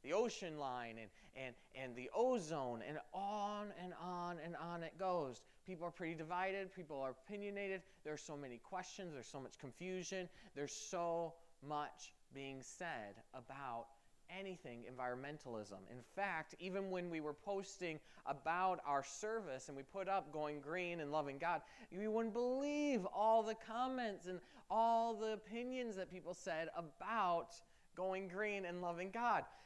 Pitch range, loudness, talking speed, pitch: 145-195 Hz, -45 LUFS, 160 wpm, 175 Hz